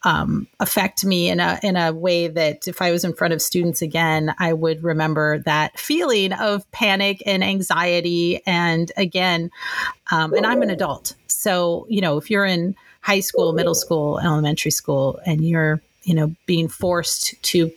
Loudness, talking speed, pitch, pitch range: -20 LUFS, 175 wpm, 170 Hz, 160-185 Hz